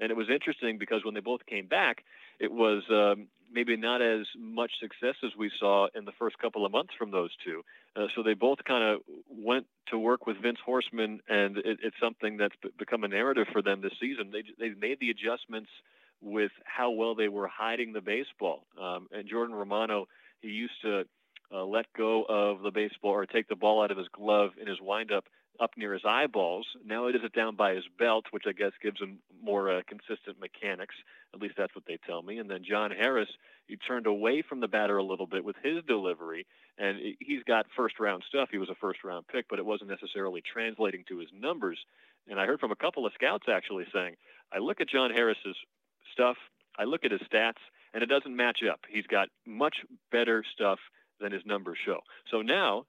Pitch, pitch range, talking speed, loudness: 110 Hz, 105-120 Hz, 220 wpm, -31 LUFS